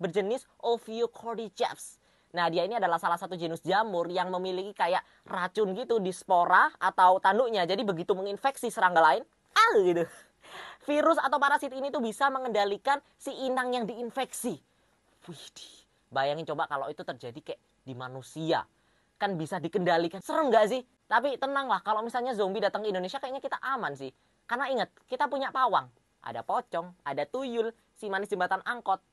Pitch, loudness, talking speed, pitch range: 210 Hz, -29 LUFS, 160 wpm, 185-255 Hz